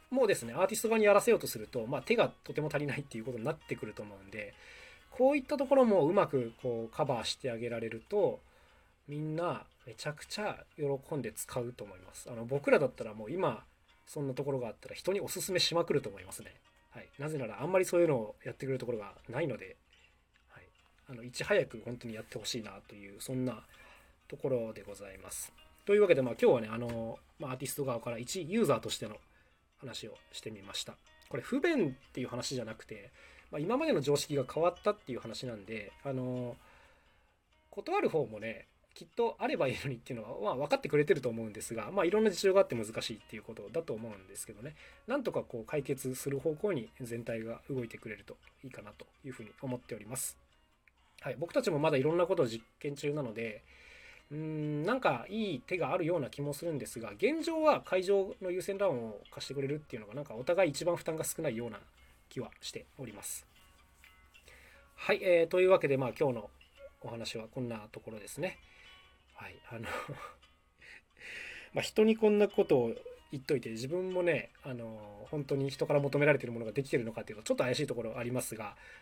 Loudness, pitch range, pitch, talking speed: -34 LUFS, 115-175 Hz, 135 Hz, 430 characters per minute